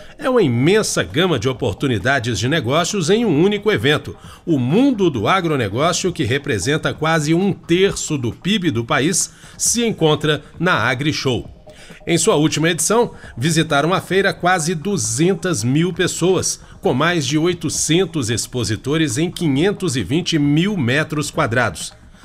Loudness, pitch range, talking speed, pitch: -17 LUFS, 140-180 Hz, 140 wpm, 160 Hz